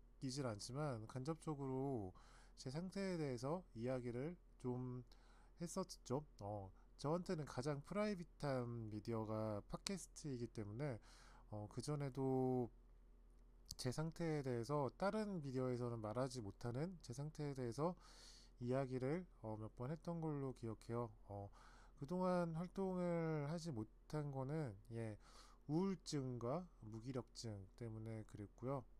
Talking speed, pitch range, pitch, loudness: 265 characters per minute, 115-155 Hz, 130 Hz, -47 LUFS